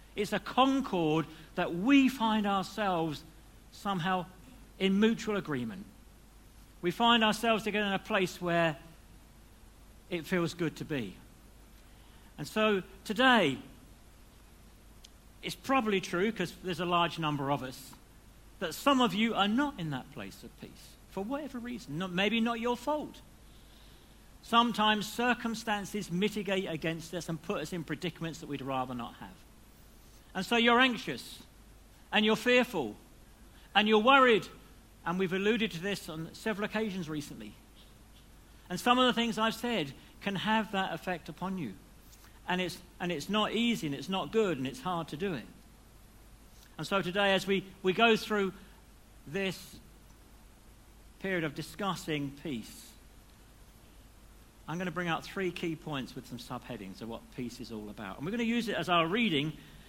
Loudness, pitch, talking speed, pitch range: -31 LUFS, 180 Hz, 160 wpm, 140-215 Hz